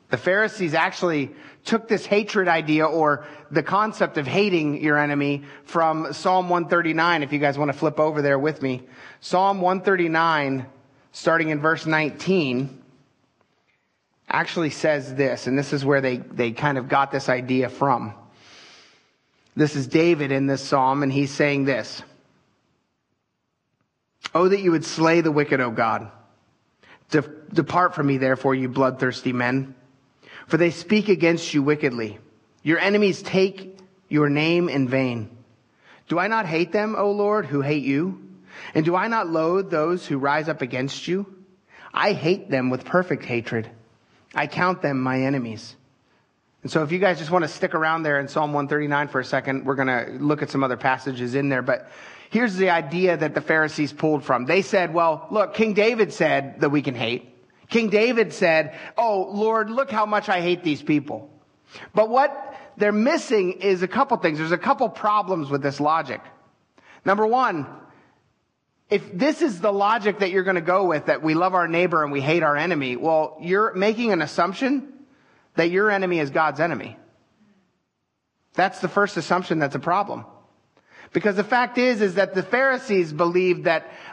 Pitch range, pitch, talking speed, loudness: 140-190 Hz, 160 Hz, 175 wpm, -22 LUFS